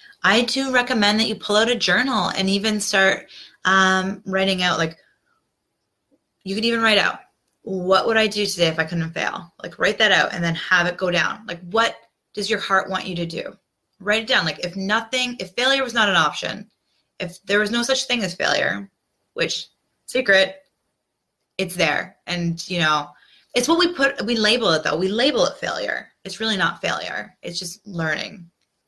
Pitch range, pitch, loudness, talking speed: 180-225 Hz, 195 Hz, -20 LUFS, 195 wpm